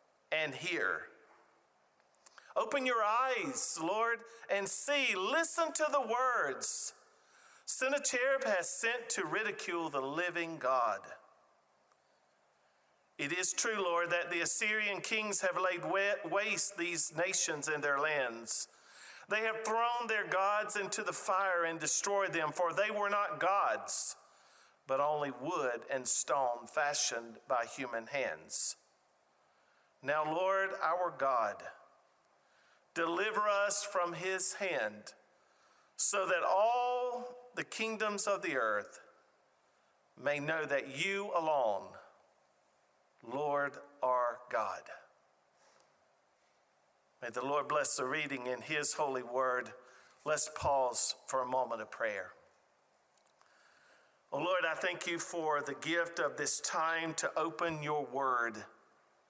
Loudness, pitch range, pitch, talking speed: -33 LUFS, 145-210 Hz, 175 Hz, 120 wpm